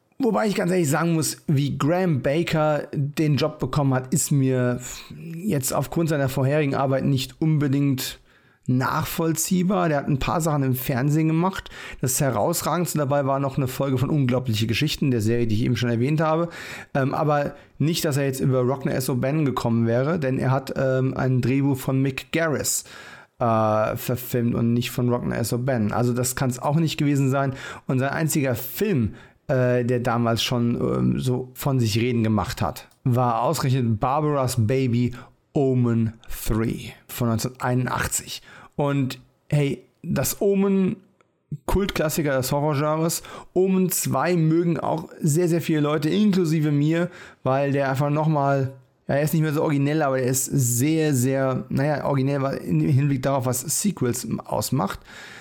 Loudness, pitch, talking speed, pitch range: -23 LUFS, 140 Hz, 160 wpm, 125-155 Hz